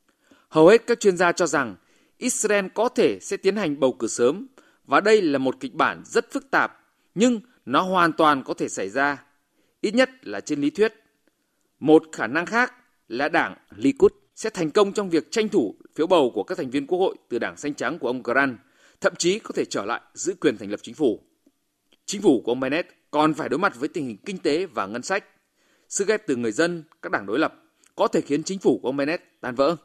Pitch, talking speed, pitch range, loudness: 200 Hz, 235 wpm, 155-260 Hz, -23 LUFS